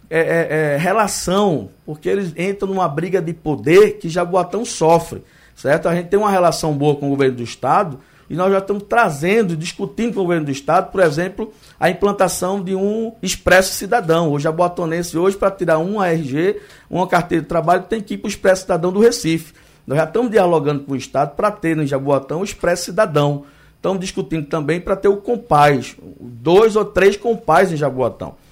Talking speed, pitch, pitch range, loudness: 195 wpm, 175 Hz, 155-200 Hz, -17 LUFS